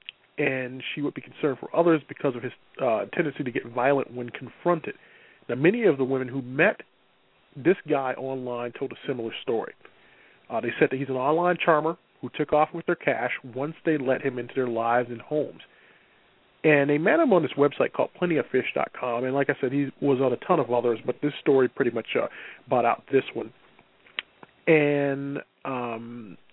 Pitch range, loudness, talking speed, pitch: 125-150 Hz, -26 LUFS, 195 wpm, 135 Hz